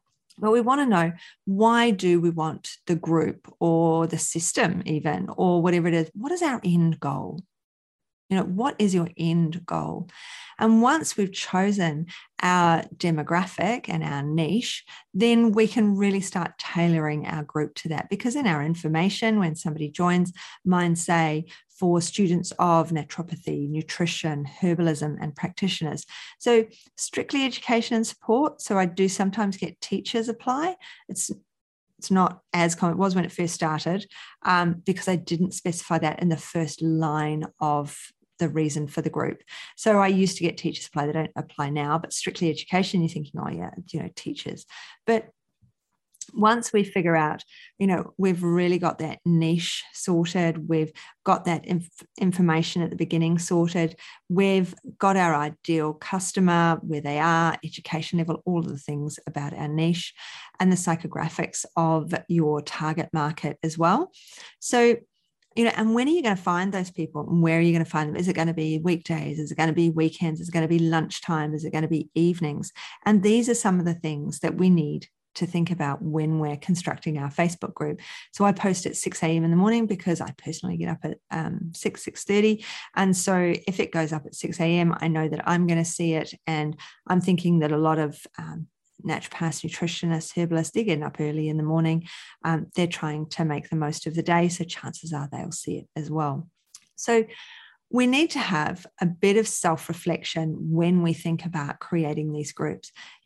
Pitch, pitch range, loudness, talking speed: 170 Hz, 160-190 Hz, -25 LUFS, 190 wpm